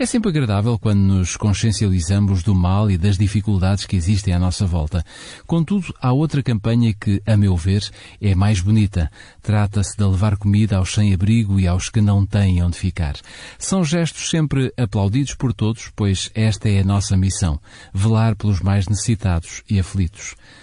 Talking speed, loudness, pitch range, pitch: 170 wpm, -19 LUFS, 95-110 Hz, 100 Hz